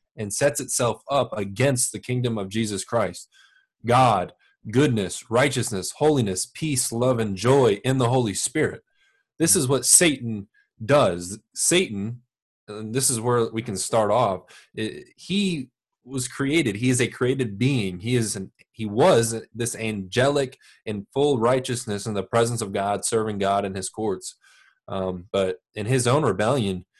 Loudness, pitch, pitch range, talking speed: -23 LUFS, 120 Hz, 105-135 Hz, 155 wpm